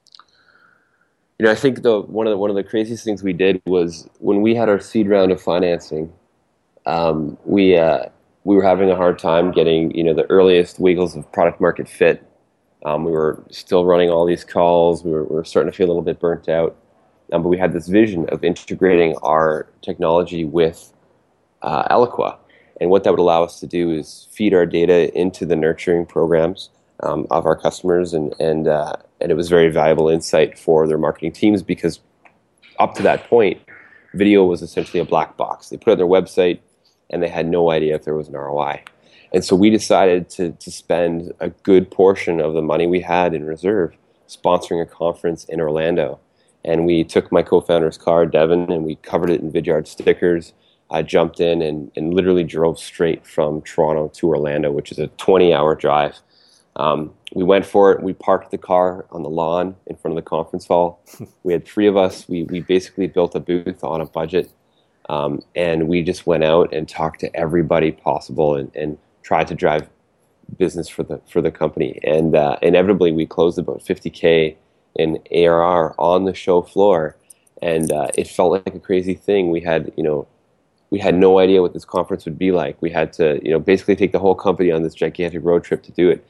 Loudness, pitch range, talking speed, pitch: -17 LUFS, 80-95 Hz, 205 wpm, 85 Hz